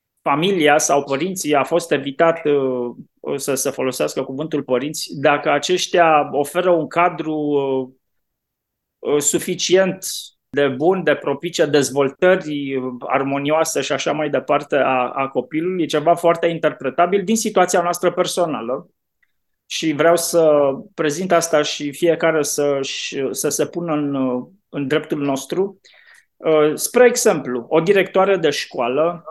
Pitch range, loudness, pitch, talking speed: 140-175 Hz, -18 LUFS, 155 Hz, 120 wpm